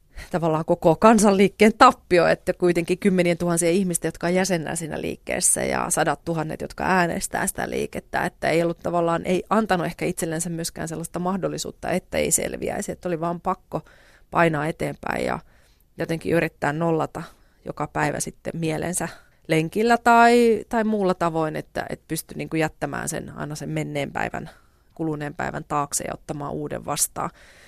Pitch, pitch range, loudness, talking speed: 170 Hz, 160-185 Hz, -23 LUFS, 150 wpm